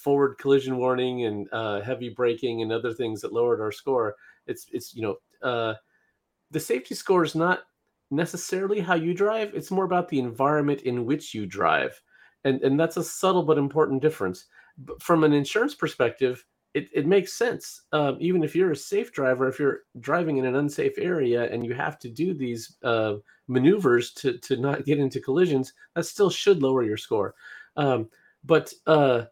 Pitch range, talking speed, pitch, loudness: 125-180 Hz, 185 wpm, 145 Hz, -25 LUFS